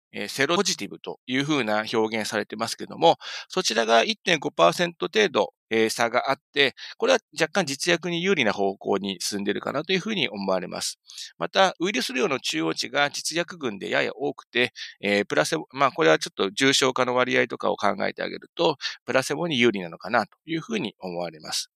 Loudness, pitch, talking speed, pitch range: -24 LUFS, 130 Hz, 385 characters per minute, 105-165 Hz